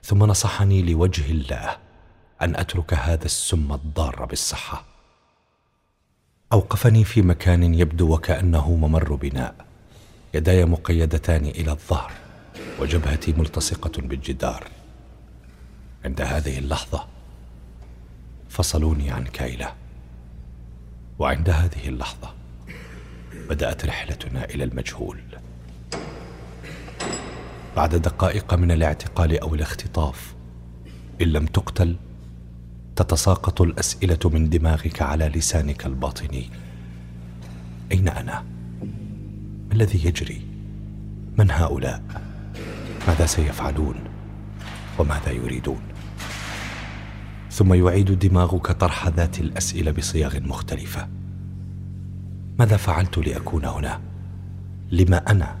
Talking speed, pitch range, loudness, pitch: 85 wpm, 65-95 Hz, -23 LUFS, 80 Hz